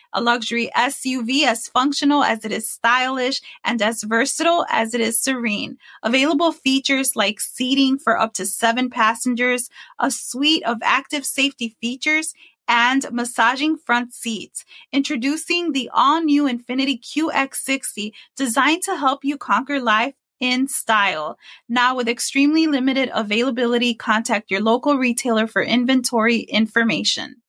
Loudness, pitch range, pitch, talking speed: -19 LUFS, 230-280 Hz, 255 Hz, 135 wpm